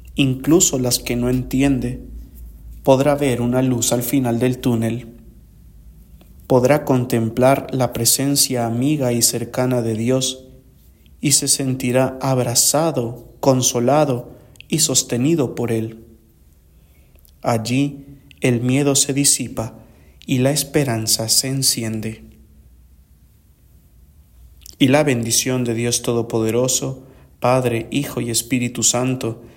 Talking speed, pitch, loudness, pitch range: 105 wpm, 125 Hz, -18 LUFS, 115-135 Hz